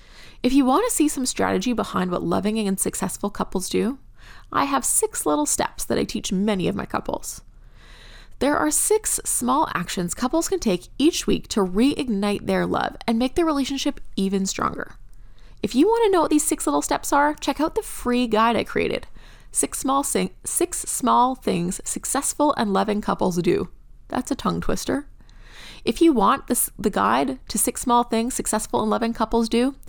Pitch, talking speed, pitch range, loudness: 245 Hz, 190 wpm, 210-295 Hz, -22 LUFS